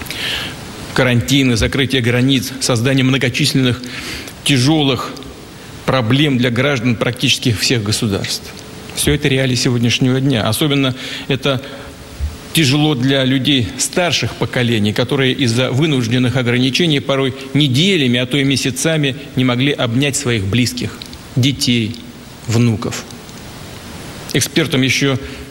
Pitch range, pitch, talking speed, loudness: 125-140 Hz, 130 Hz, 100 wpm, -15 LUFS